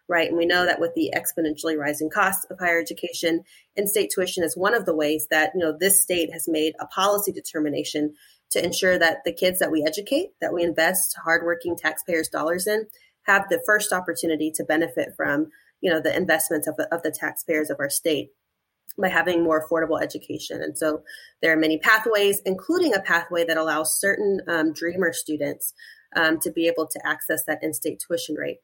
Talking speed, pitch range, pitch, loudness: 195 wpm, 155-185 Hz, 165 Hz, -23 LUFS